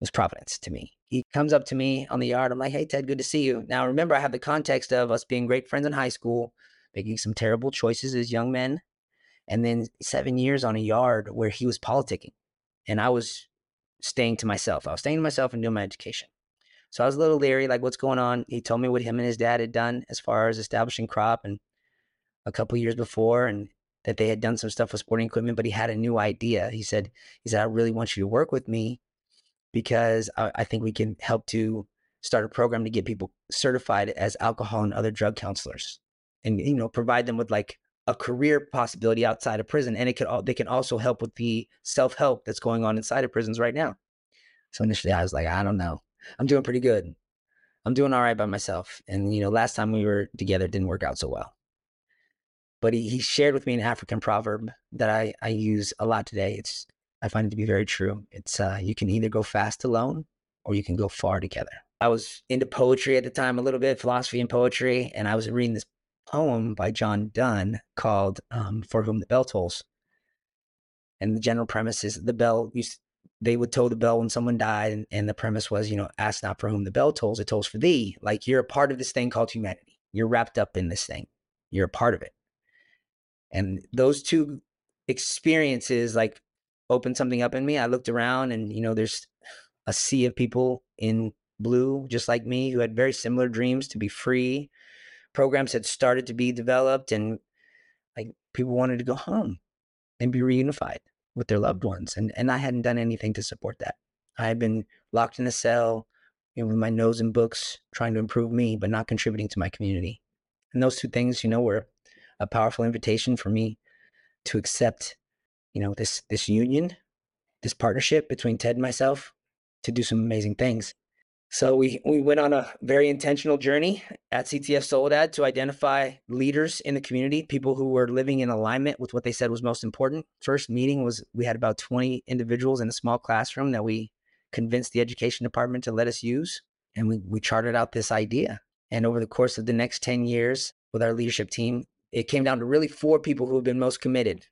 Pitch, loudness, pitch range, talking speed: 120 Hz, -26 LUFS, 110-130 Hz, 220 wpm